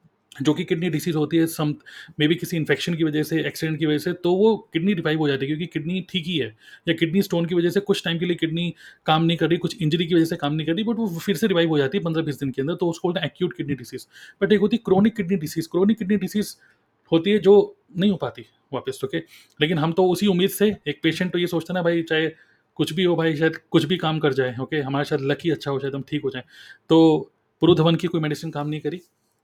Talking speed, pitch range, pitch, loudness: 285 wpm, 150-180 Hz, 165 Hz, -22 LUFS